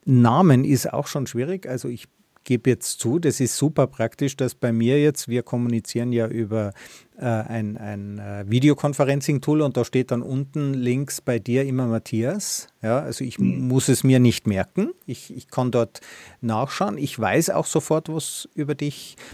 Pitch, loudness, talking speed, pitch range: 130 Hz, -22 LUFS, 180 wpm, 115-145 Hz